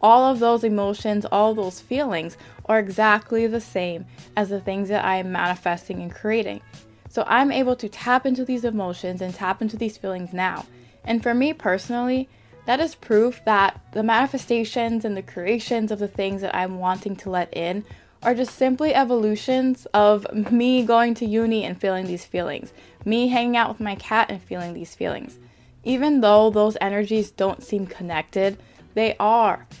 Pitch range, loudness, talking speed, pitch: 190-235 Hz, -22 LUFS, 175 wpm, 215 Hz